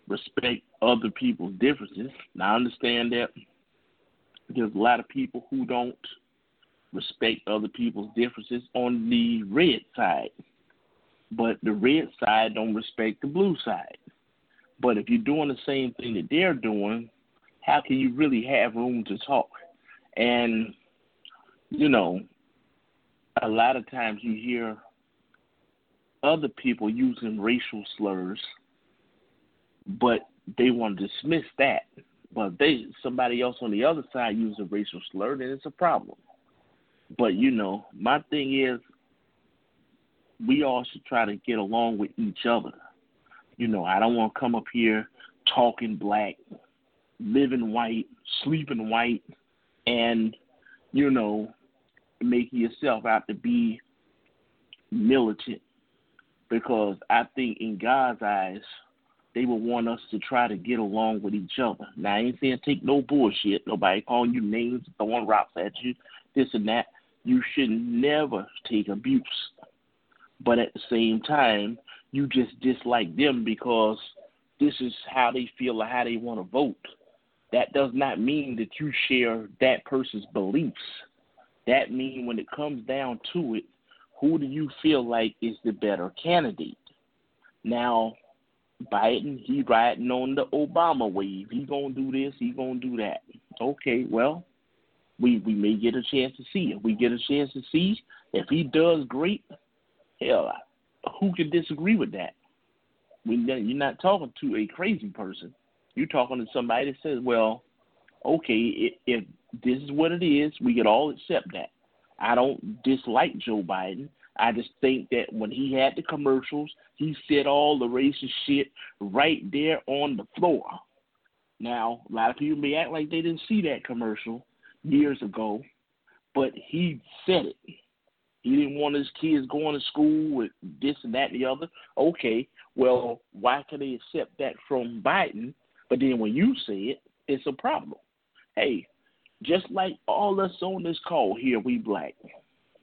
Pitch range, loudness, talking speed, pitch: 115-150 Hz, -26 LUFS, 155 wpm, 125 Hz